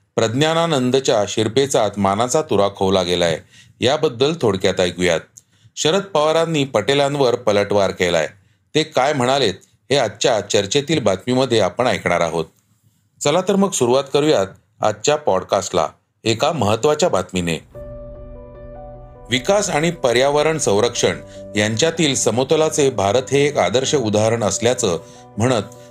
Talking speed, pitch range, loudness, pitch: 110 wpm, 100-145 Hz, -18 LUFS, 120 Hz